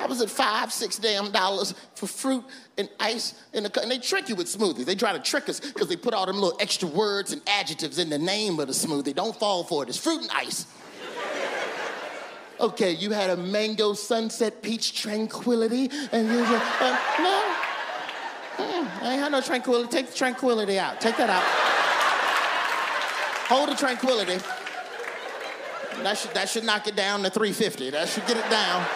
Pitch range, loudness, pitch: 200-250 Hz, -25 LUFS, 220 Hz